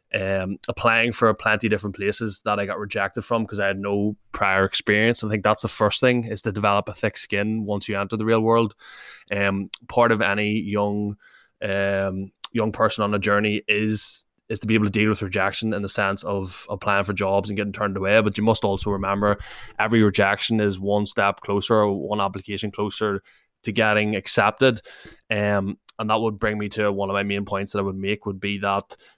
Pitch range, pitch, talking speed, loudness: 100-110 Hz, 105 Hz, 215 wpm, -23 LUFS